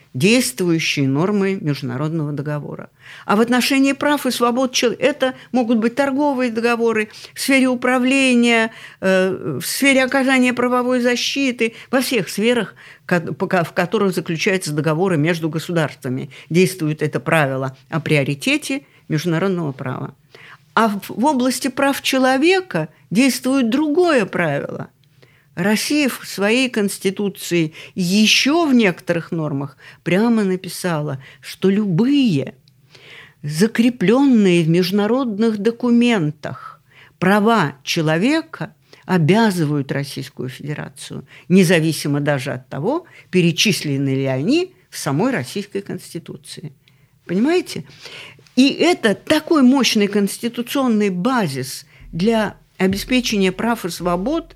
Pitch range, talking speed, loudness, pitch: 155-245 Hz, 100 wpm, -18 LUFS, 195 Hz